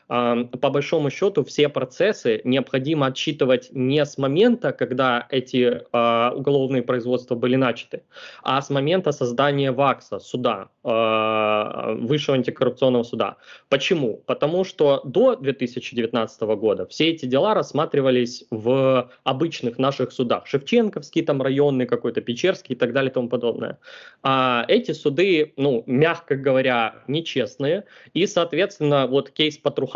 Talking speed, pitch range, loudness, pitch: 125 wpm, 125-145 Hz, -21 LUFS, 130 Hz